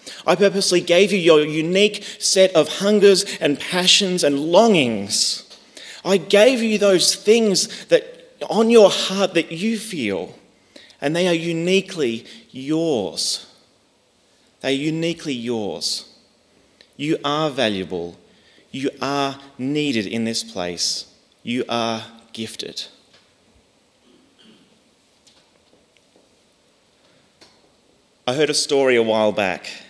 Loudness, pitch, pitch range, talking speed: -18 LUFS, 155 Hz, 120-195 Hz, 105 wpm